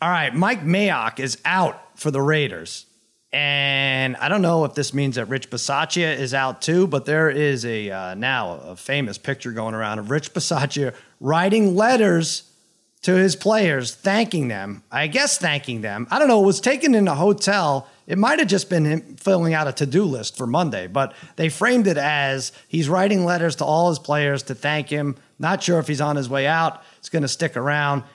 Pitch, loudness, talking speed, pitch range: 150 Hz, -20 LUFS, 205 wpm, 135-180 Hz